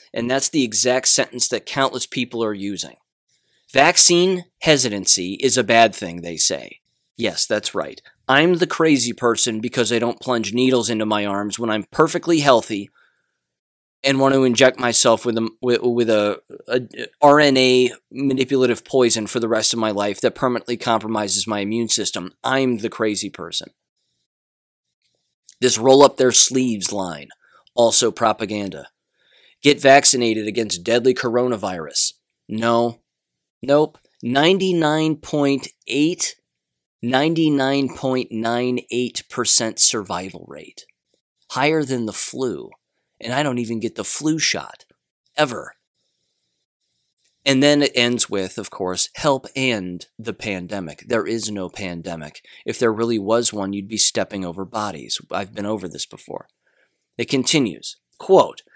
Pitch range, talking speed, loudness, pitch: 105-135 Hz, 135 wpm, -18 LUFS, 120 Hz